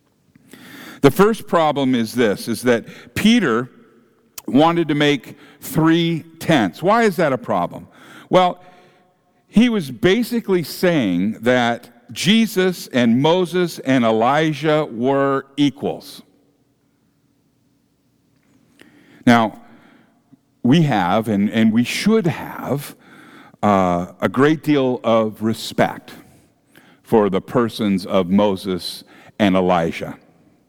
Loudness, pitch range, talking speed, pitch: -18 LUFS, 115-180 Hz, 100 wpm, 140 Hz